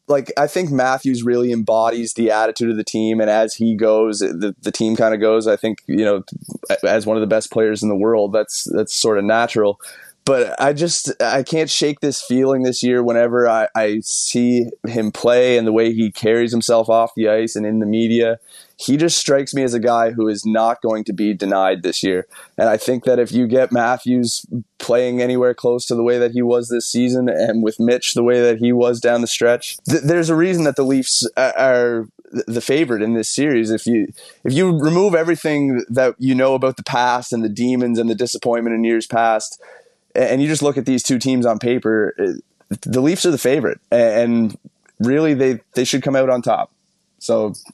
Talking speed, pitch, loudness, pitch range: 215 wpm, 120 Hz, -17 LUFS, 110-130 Hz